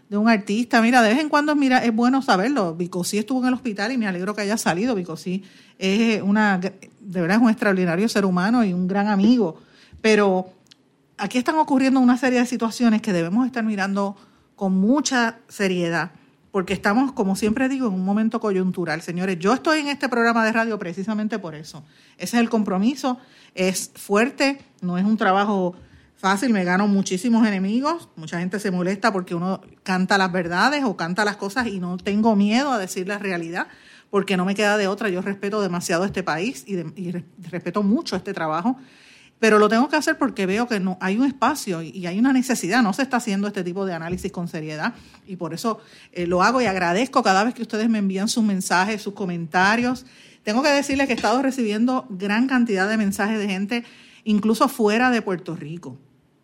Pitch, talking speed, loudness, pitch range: 205 Hz, 205 wpm, -21 LUFS, 185-235 Hz